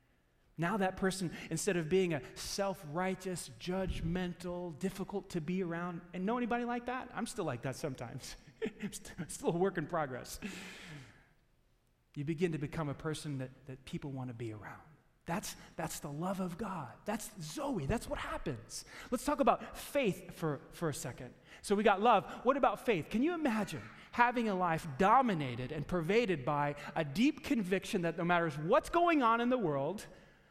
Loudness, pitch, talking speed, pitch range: -35 LUFS, 180 Hz, 180 wpm, 155-210 Hz